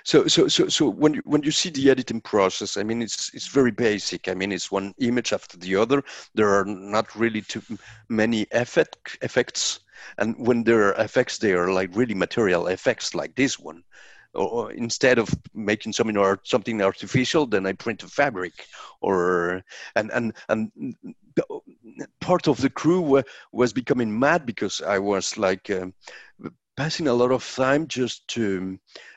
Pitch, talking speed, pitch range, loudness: 115 Hz, 175 wpm, 100-135 Hz, -23 LUFS